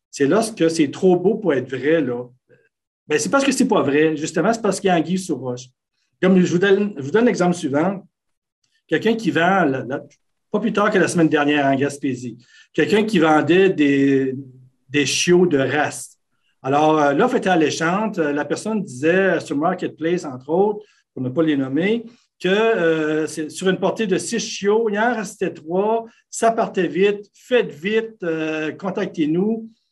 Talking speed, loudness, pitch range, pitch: 180 wpm, -19 LUFS, 145-210 Hz, 170 Hz